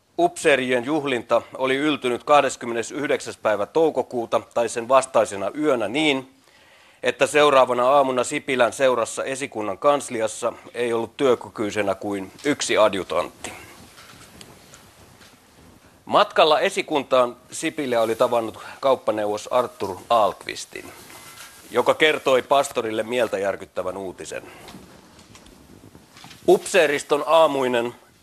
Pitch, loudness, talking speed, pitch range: 125 Hz, -21 LUFS, 85 wpm, 115-145 Hz